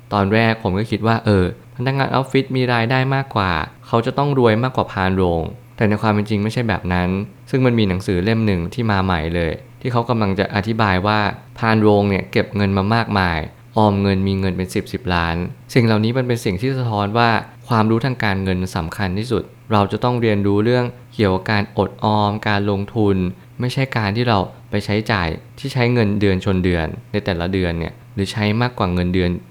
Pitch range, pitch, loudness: 95-120 Hz, 105 Hz, -19 LUFS